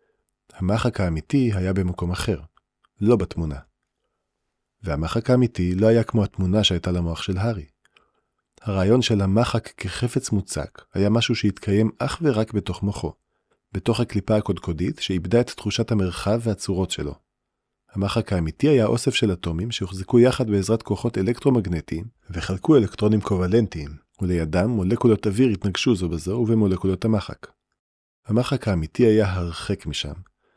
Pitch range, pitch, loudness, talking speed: 90-115 Hz, 100 Hz, -22 LUFS, 130 wpm